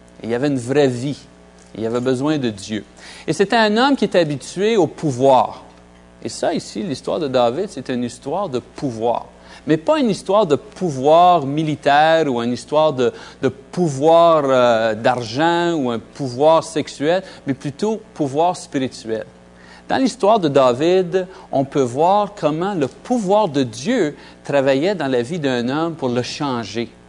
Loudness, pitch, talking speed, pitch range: -18 LUFS, 145 Hz, 170 wpm, 120-170 Hz